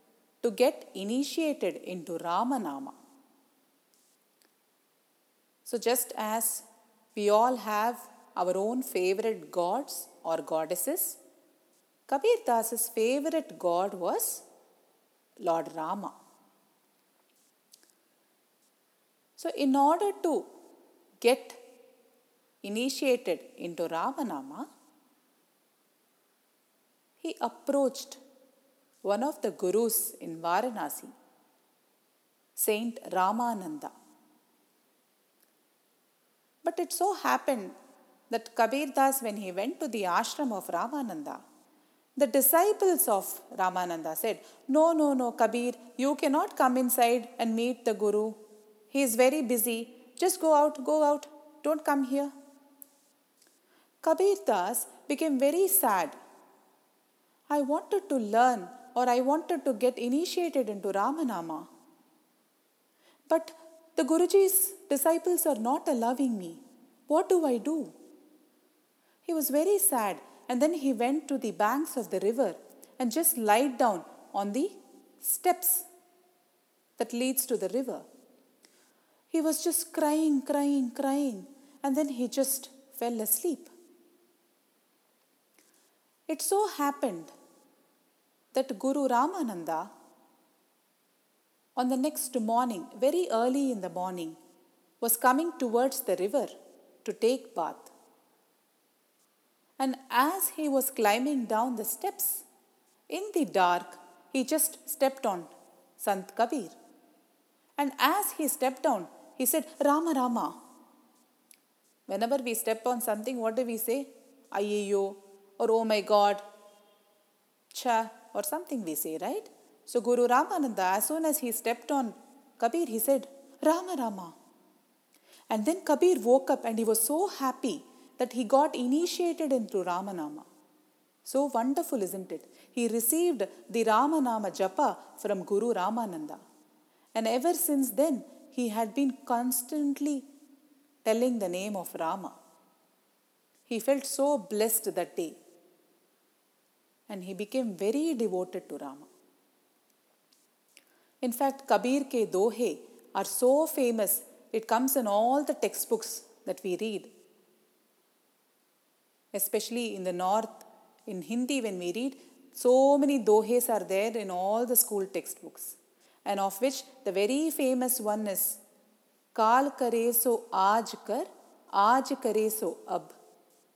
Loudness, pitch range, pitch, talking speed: -29 LUFS, 225-300 Hz, 260 Hz, 120 wpm